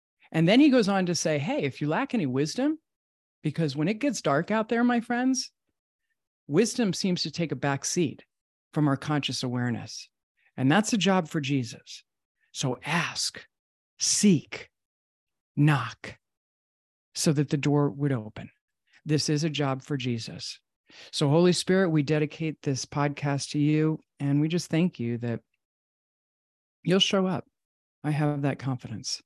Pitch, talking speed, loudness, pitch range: 150 Hz, 160 wpm, -26 LUFS, 135-180 Hz